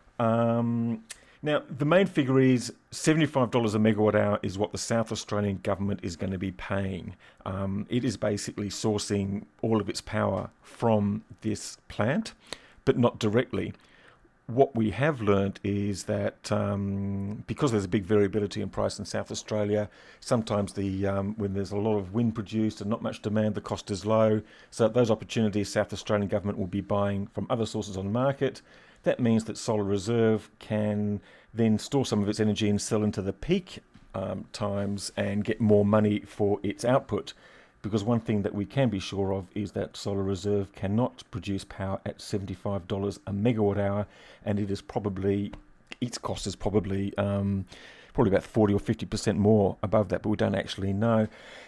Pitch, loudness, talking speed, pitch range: 105 Hz, -28 LUFS, 180 wpm, 100-110 Hz